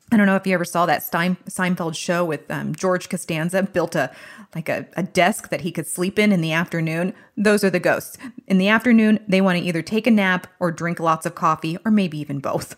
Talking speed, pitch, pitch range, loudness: 245 wpm, 180 Hz, 165-200 Hz, -20 LUFS